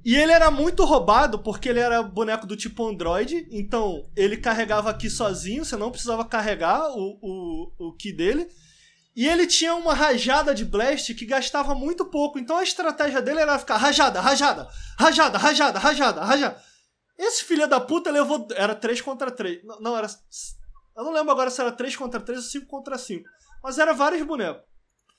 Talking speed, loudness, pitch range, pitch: 185 wpm, -22 LUFS, 220-300 Hz, 265 Hz